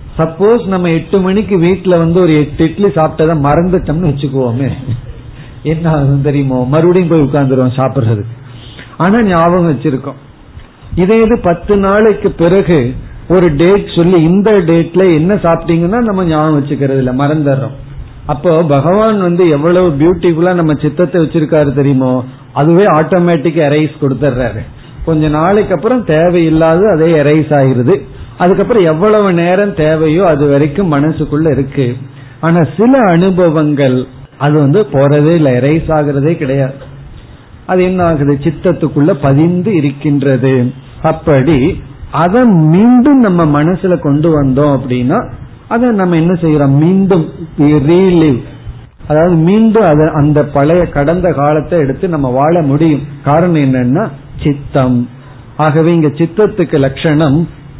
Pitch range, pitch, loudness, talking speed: 140-175 Hz, 155 Hz, -10 LUFS, 95 wpm